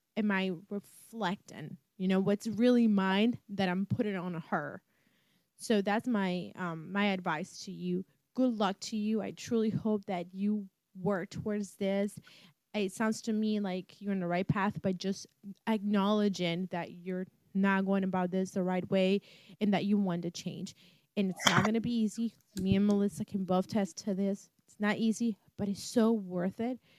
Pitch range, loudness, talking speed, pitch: 185-210 Hz, -33 LUFS, 185 wpm, 195 Hz